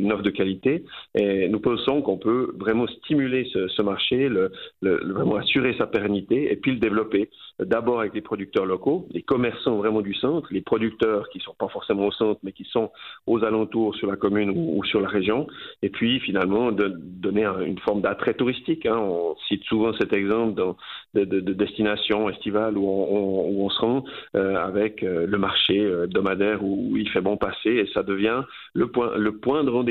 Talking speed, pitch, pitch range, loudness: 200 wpm, 105 Hz, 100-115 Hz, -24 LUFS